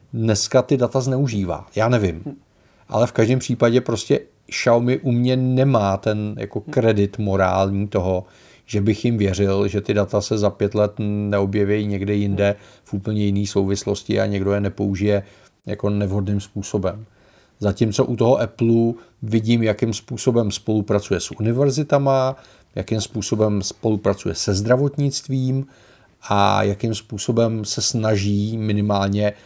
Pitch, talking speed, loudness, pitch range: 105 Hz, 135 wpm, -20 LUFS, 100-120 Hz